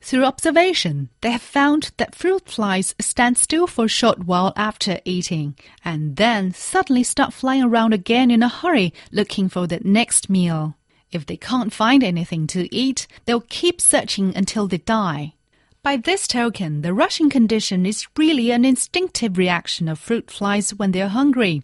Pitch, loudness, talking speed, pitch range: 220 Hz, -19 LUFS, 170 wpm, 180-255 Hz